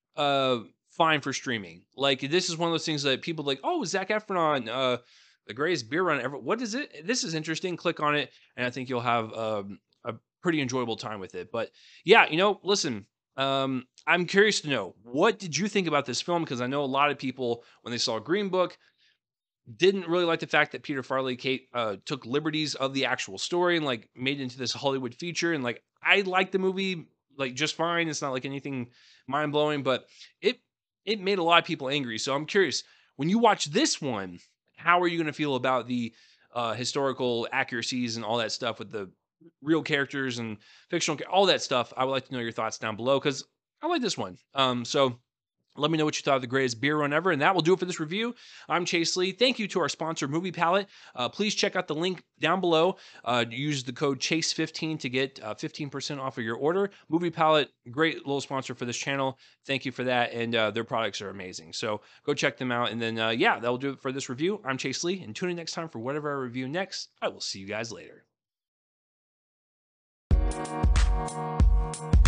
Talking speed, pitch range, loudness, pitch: 225 wpm, 125-170 Hz, -28 LUFS, 140 Hz